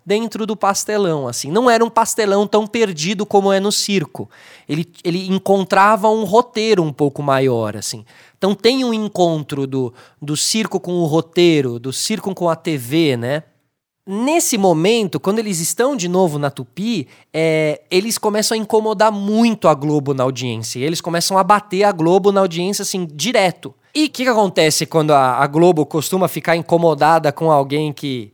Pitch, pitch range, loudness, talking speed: 180 Hz, 150-210 Hz, -16 LUFS, 175 wpm